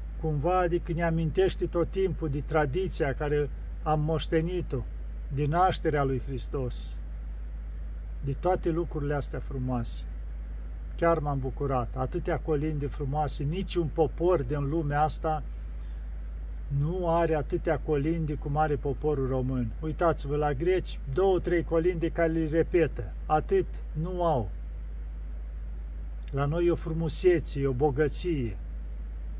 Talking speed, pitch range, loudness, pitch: 120 wpm, 115-165 Hz, -29 LUFS, 150 Hz